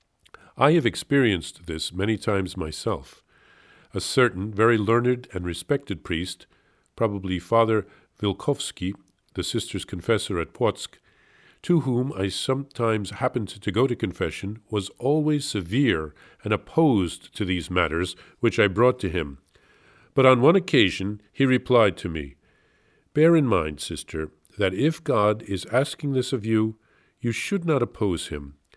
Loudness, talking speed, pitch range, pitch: -24 LUFS, 145 wpm, 90-125 Hz, 105 Hz